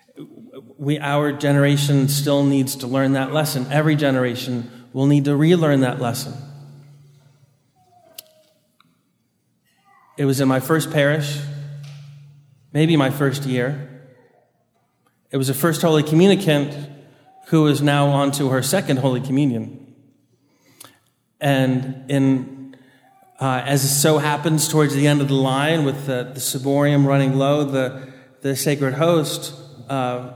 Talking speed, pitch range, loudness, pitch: 130 wpm, 135-145 Hz, -19 LUFS, 140 Hz